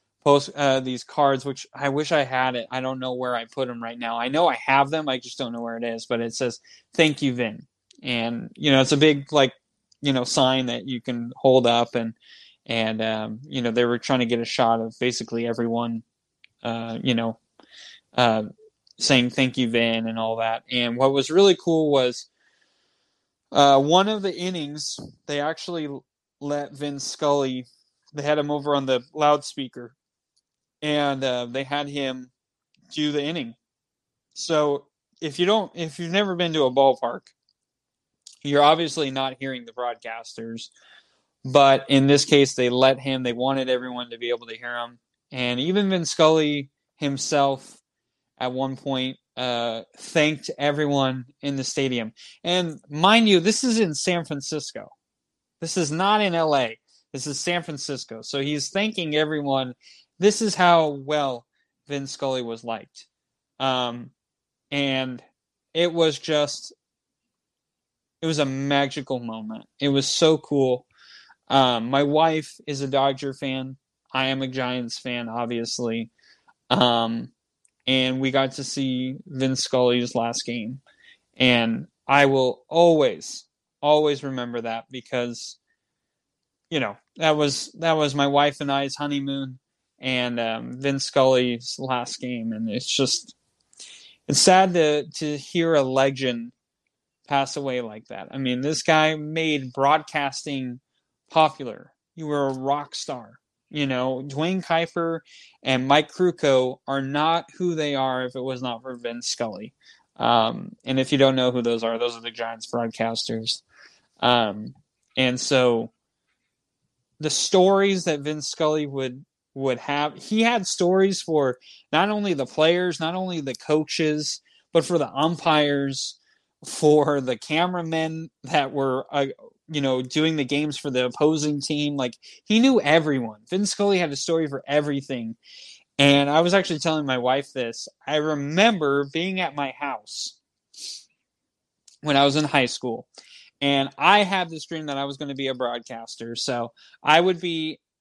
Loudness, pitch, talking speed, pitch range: -23 LUFS, 140 Hz, 160 wpm, 125-155 Hz